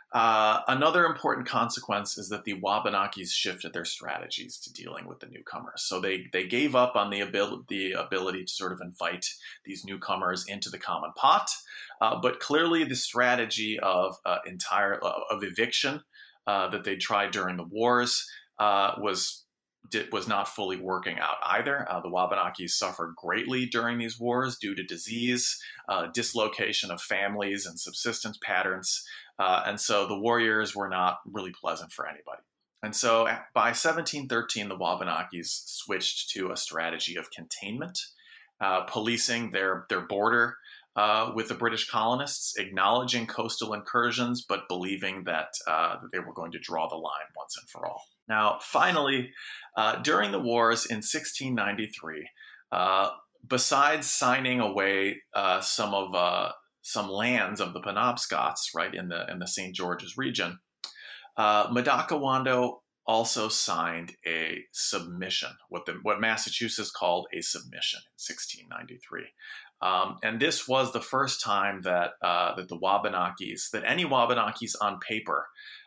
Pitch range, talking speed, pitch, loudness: 95-120 Hz, 155 wpm, 105 Hz, -28 LUFS